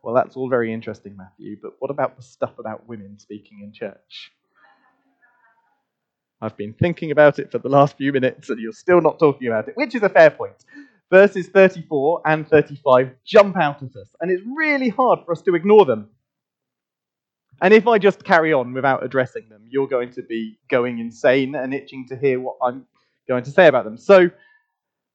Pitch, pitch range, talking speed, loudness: 140 Hz, 125-190 Hz, 195 wpm, -18 LUFS